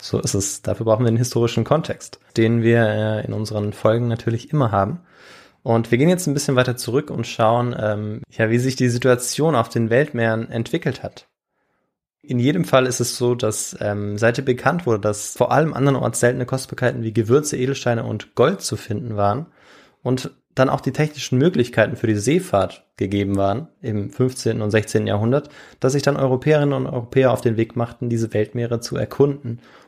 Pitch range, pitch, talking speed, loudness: 110-135 Hz, 120 Hz, 190 wpm, -20 LUFS